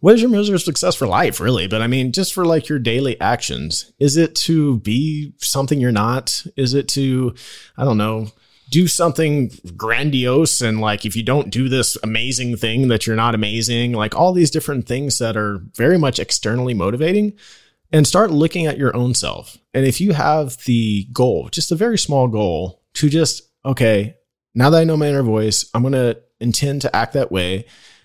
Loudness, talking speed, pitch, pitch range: -17 LUFS, 200 wpm, 130 Hz, 115-155 Hz